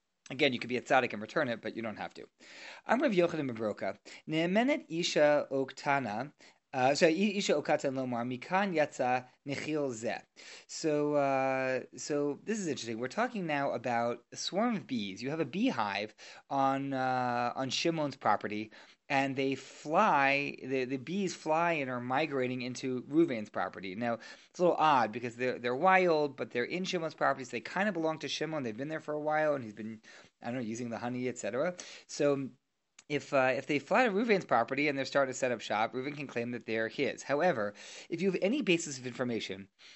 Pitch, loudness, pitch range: 135 Hz, -32 LUFS, 125-155 Hz